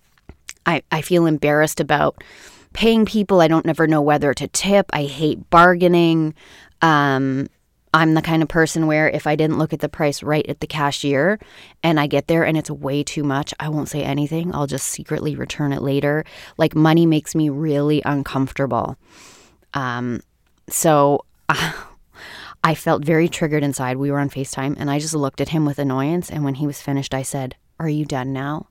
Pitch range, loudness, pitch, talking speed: 140-160 Hz, -19 LUFS, 150 Hz, 190 wpm